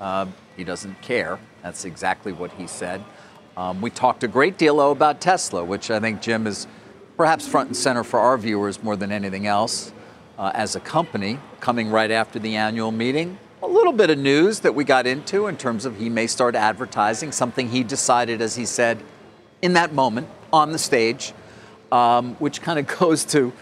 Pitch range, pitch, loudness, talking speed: 110-145 Hz, 120 Hz, -21 LUFS, 200 wpm